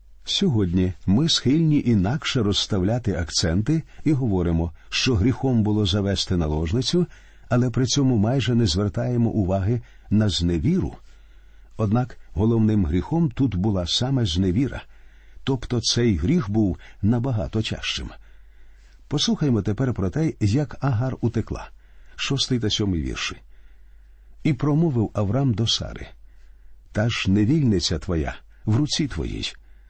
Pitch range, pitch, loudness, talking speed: 90-125 Hz, 105 Hz, -23 LUFS, 115 wpm